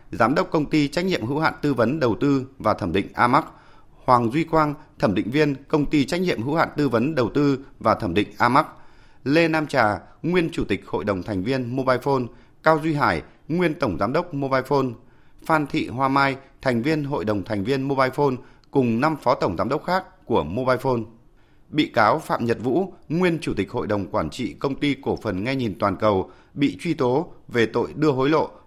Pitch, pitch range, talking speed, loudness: 140 Hz, 125-155 Hz, 225 wpm, -22 LUFS